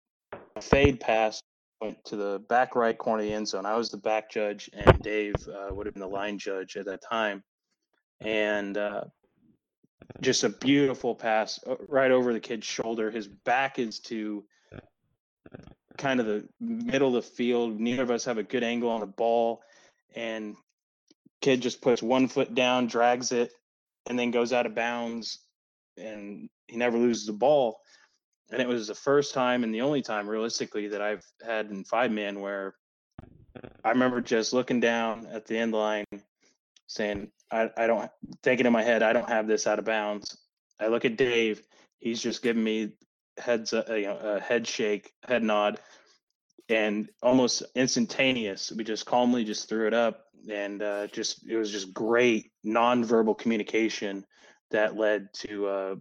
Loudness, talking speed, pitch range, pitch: -28 LUFS, 175 wpm, 105-120 Hz, 115 Hz